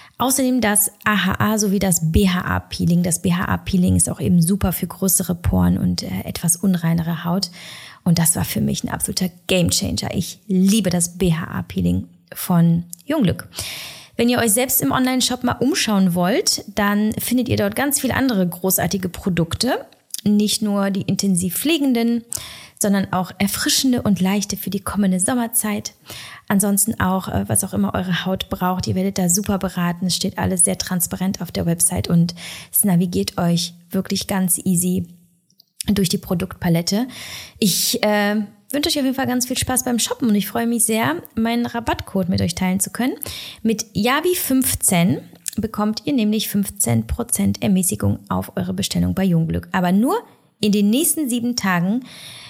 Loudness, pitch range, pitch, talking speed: -19 LUFS, 175-220 Hz, 195 Hz, 160 wpm